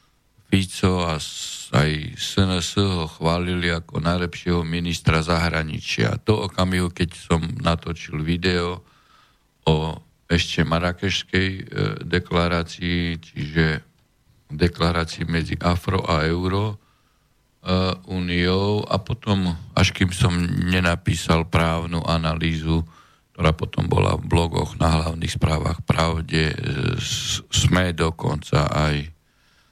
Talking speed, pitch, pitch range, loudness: 95 wpm, 85 Hz, 80-95 Hz, -22 LUFS